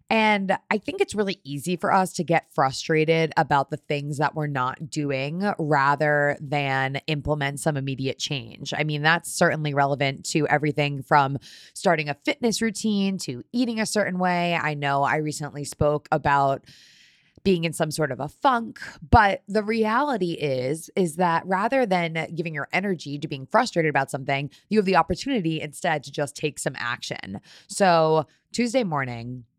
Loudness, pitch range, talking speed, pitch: -24 LUFS, 145-185 Hz, 170 wpm, 155 Hz